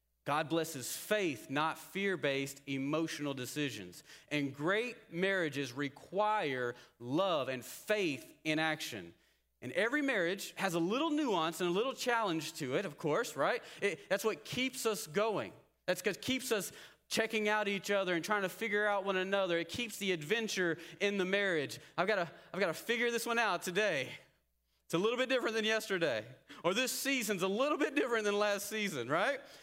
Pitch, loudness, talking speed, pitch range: 195 Hz, -35 LUFS, 180 wpm, 160-220 Hz